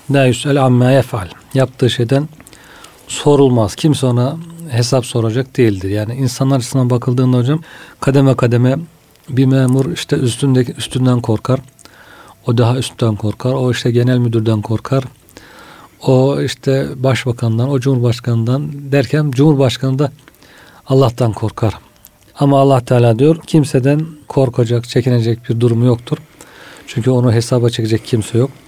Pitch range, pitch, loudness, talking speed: 120-135 Hz, 130 Hz, -14 LUFS, 120 wpm